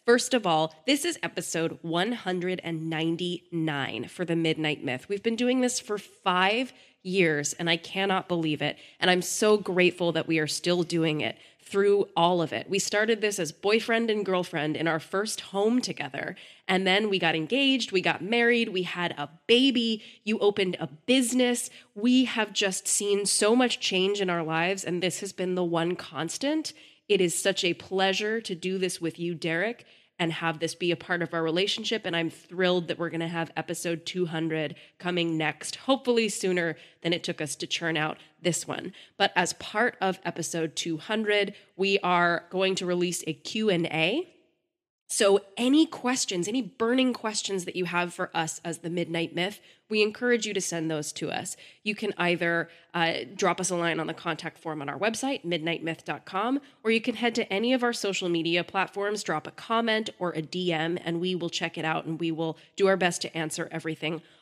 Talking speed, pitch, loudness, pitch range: 195 wpm, 180 Hz, -27 LUFS, 165-210 Hz